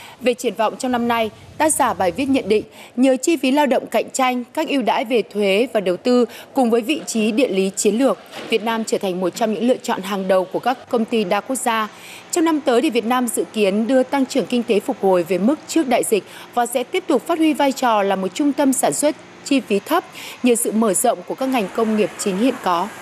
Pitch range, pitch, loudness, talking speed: 215-270 Hz, 245 Hz, -19 LUFS, 265 wpm